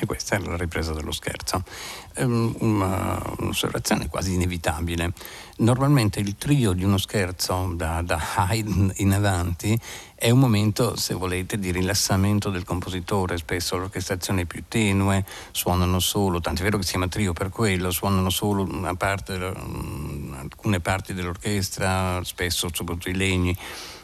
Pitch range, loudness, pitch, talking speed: 90-105 Hz, -24 LUFS, 95 Hz, 135 wpm